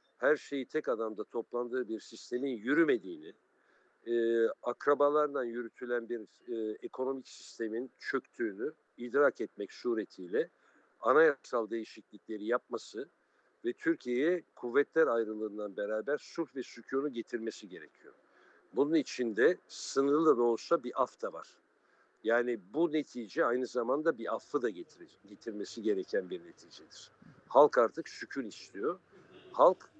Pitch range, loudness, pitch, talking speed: 115-165 Hz, -33 LUFS, 130 Hz, 115 wpm